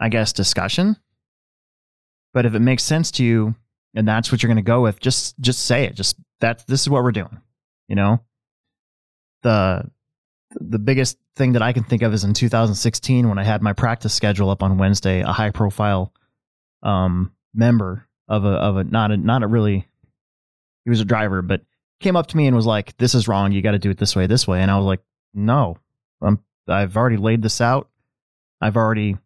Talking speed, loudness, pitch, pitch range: 210 wpm, -19 LUFS, 110 Hz, 100-120 Hz